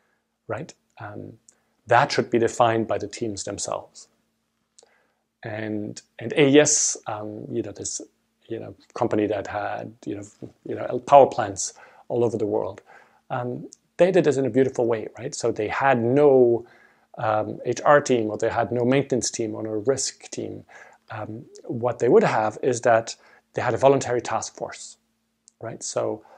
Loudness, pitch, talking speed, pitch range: -22 LUFS, 115 Hz, 170 wpm, 110-130 Hz